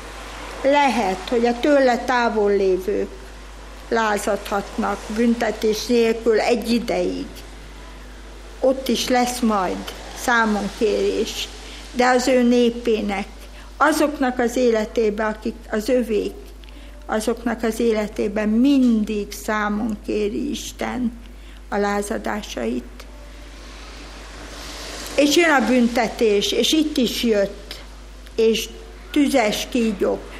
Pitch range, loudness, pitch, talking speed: 215-250 Hz, -20 LUFS, 235 Hz, 90 wpm